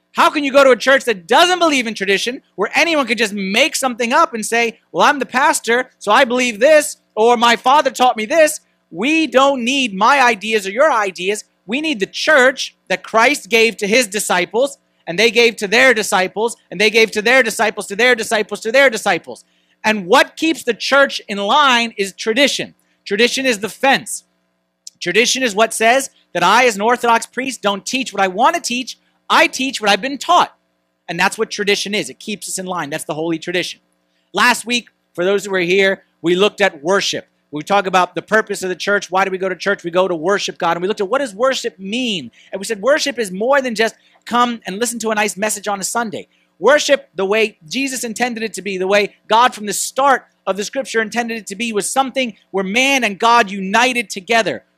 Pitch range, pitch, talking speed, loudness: 195-255 Hz, 225 Hz, 225 wpm, -15 LUFS